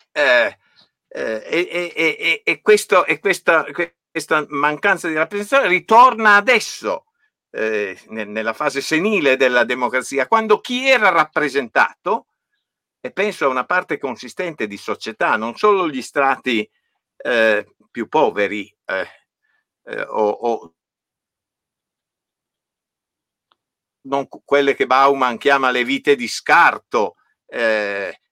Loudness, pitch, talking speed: -17 LUFS, 140 Hz, 110 wpm